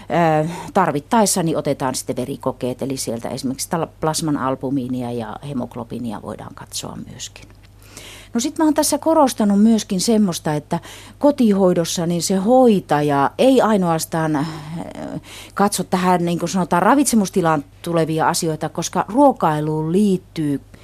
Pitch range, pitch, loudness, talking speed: 140-200 Hz, 165 Hz, -18 LUFS, 120 wpm